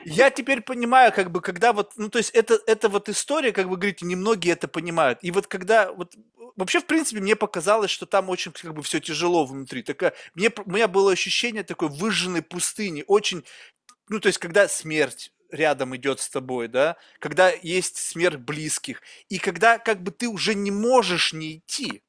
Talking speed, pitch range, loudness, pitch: 190 wpm, 170-220 Hz, -23 LUFS, 195 Hz